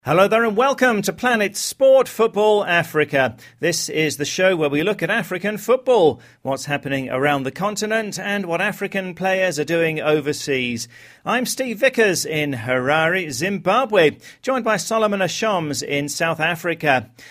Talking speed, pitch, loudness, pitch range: 155 wpm, 185 Hz, -19 LUFS, 150-215 Hz